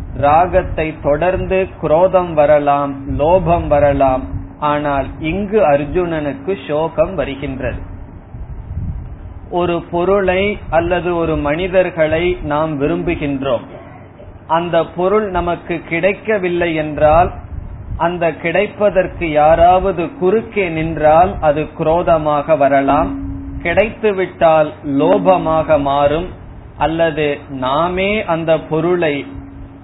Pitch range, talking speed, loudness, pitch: 140-175 Hz, 70 wpm, -15 LUFS, 155 Hz